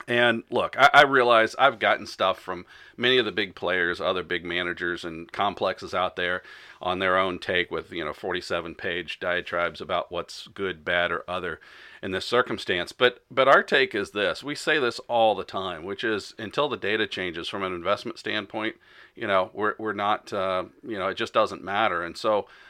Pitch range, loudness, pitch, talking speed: 90-105 Hz, -25 LUFS, 95 Hz, 200 wpm